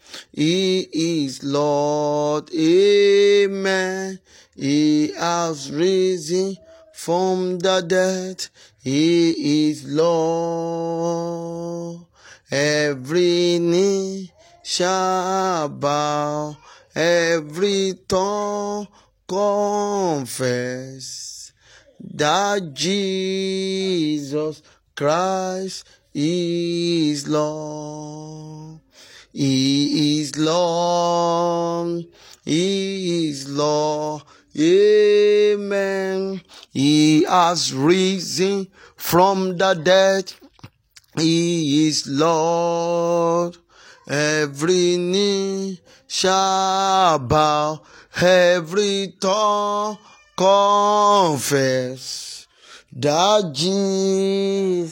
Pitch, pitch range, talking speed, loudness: 175 Hz, 150-190 Hz, 55 wpm, -19 LUFS